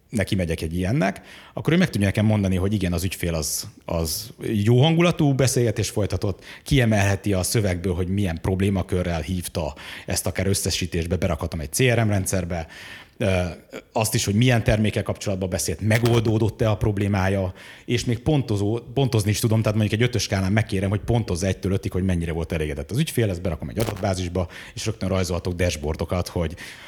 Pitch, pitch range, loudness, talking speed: 100 Hz, 90-110 Hz, -23 LUFS, 165 wpm